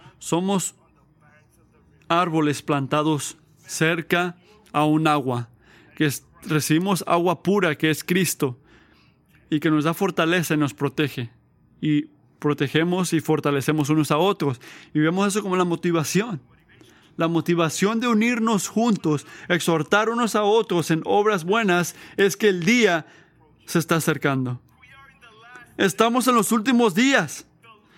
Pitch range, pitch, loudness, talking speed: 150-195 Hz, 165 Hz, -22 LUFS, 130 wpm